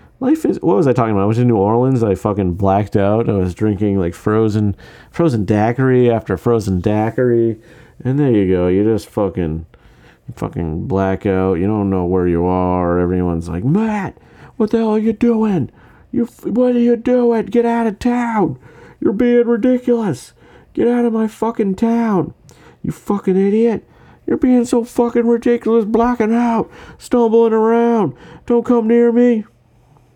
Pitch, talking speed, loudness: 155 Hz, 170 wpm, -16 LUFS